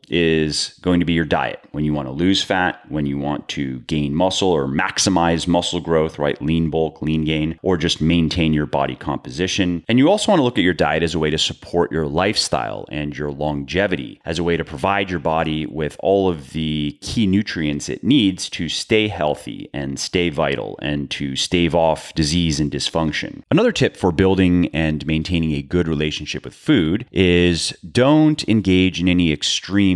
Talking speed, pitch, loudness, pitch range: 195 wpm, 80 Hz, -19 LUFS, 75-90 Hz